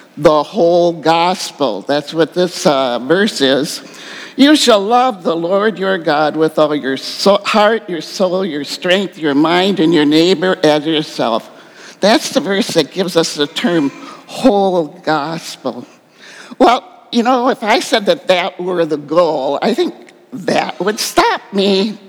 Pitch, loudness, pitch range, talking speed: 180 Hz, -14 LUFS, 160-215 Hz, 160 wpm